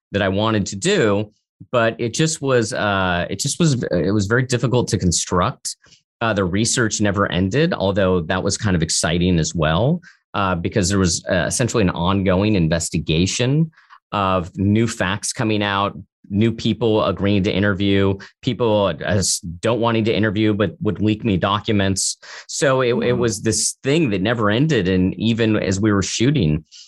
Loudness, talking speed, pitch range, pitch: -19 LUFS, 170 wpm, 95-115 Hz, 105 Hz